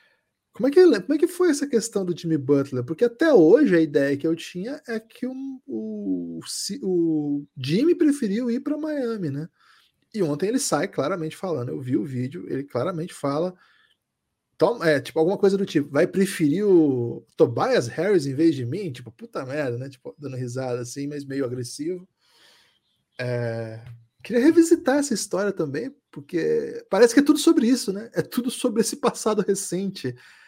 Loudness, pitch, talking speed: -23 LUFS, 175 Hz, 180 wpm